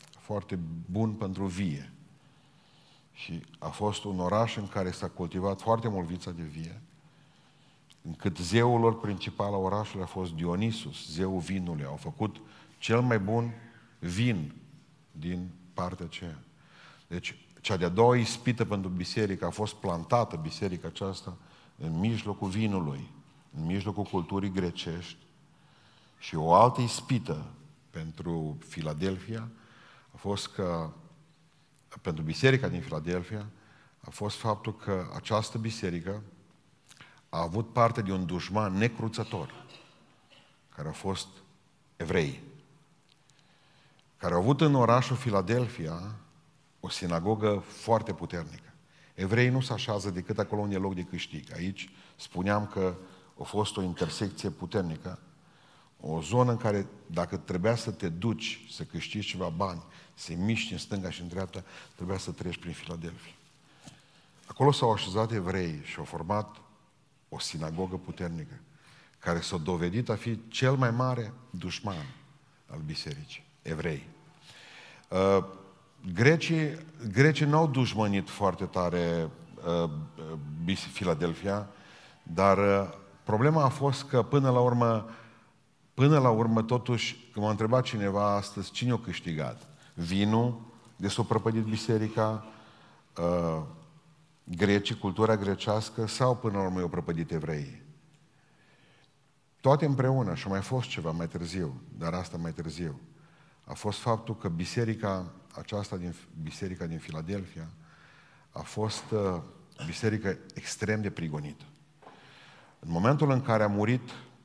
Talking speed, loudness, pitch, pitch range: 125 wpm, -30 LUFS, 105 Hz, 90-125 Hz